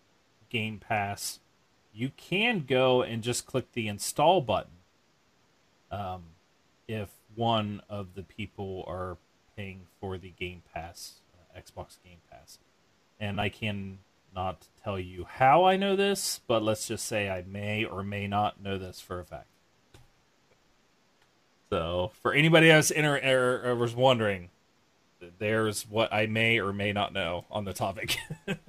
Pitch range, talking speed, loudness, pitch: 95-120 Hz, 150 wpm, -28 LUFS, 105 Hz